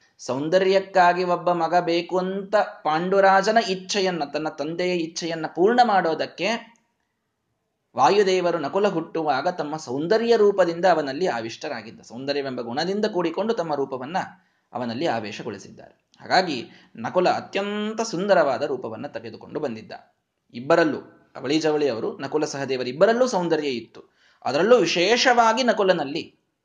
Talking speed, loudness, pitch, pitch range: 105 wpm, -22 LUFS, 180 Hz, 155-200 Hz